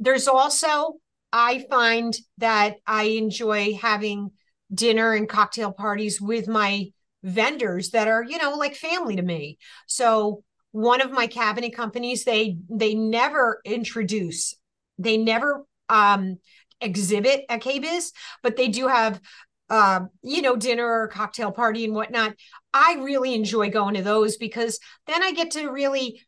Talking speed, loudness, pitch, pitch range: 150 wpm, -22 LUFS, 225 Hz, 210-255 Hz